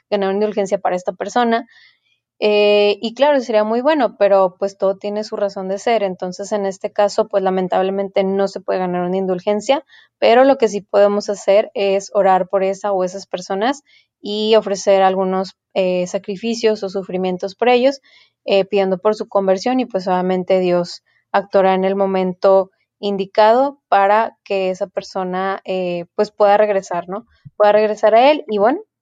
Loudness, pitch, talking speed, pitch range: -17 LUFS, 200 Hz, 170 wpm, 190-215 Hz